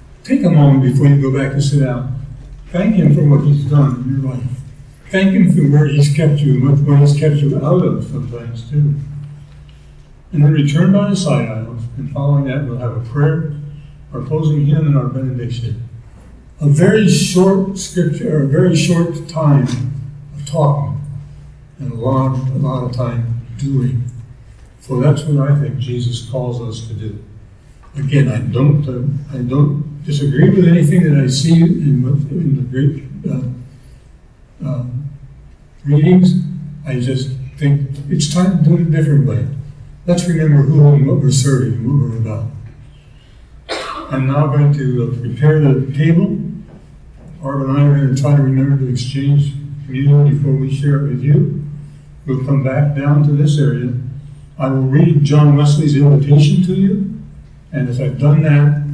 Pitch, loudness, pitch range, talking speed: 140 Hz, -14 LUFS, 130-150 Hz, 170 wpm